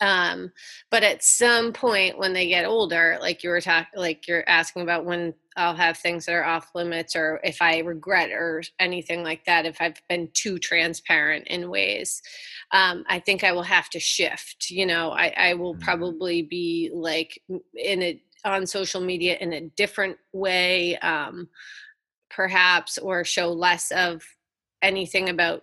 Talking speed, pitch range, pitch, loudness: 170 wpm, 170-190 Hz, 175 Hz, -22 LUFS